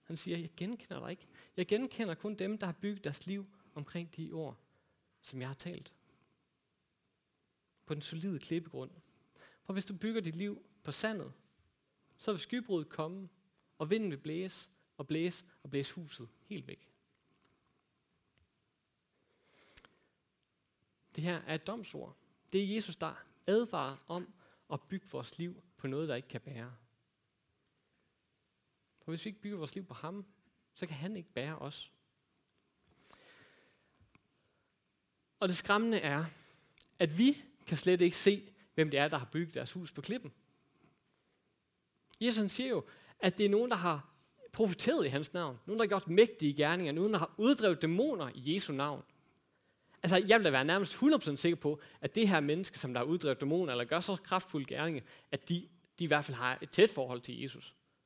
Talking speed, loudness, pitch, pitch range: 175 wpm, -35 LUFS, 175 Hz, 150-200 Hz